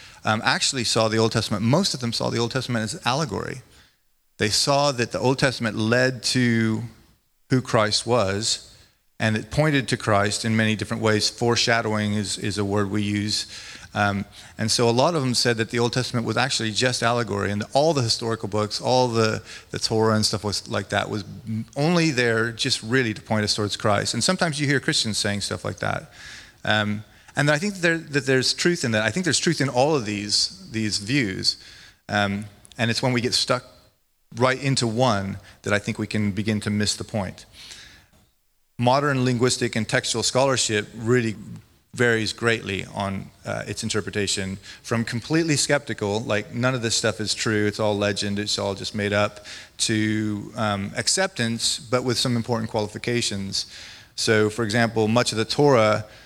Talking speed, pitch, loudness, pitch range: 190 wpm, 110 Hz, -23 LUFS, 105-125 Hz